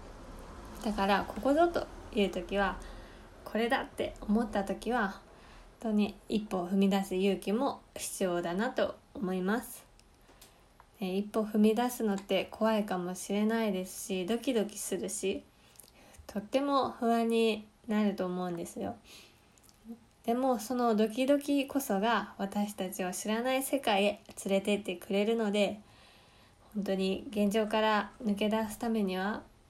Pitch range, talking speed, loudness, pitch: 190-225 Hz, 270 characters per minute, -32 LUFS, 205 Hz